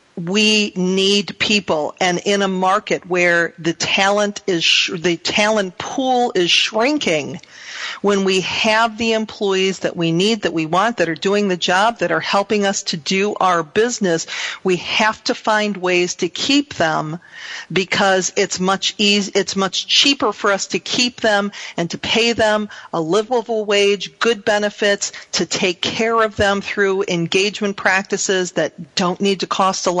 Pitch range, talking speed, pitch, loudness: 185-215 Hz, 170 wpm, 200 Hz, -17 LUFS